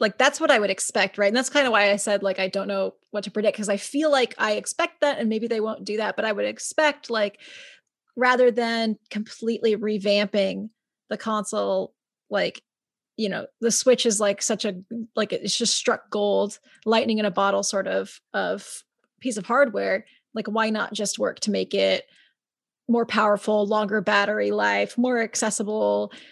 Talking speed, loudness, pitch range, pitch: 190 wpm, -23 LUFS, 205-235 Hz, 215 Hz